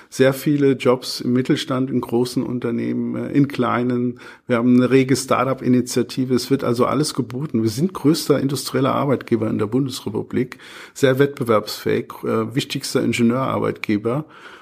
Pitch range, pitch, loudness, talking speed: 120-135 Hz, 125 Hz, -20 LUFS, 130 wpm